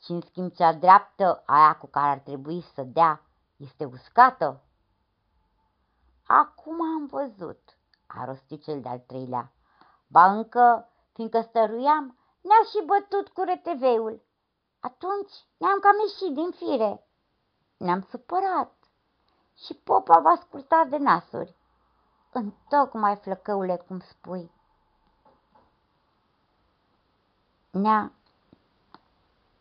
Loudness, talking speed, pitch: -23 LUFS, 105 wpm, 220 Hz